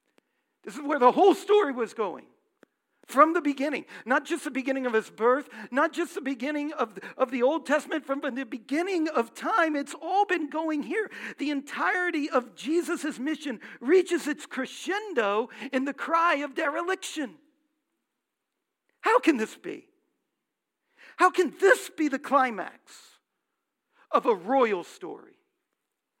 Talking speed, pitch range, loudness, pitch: 145 wpm, 270-345 Hz, -27 LUFS, 300 Hz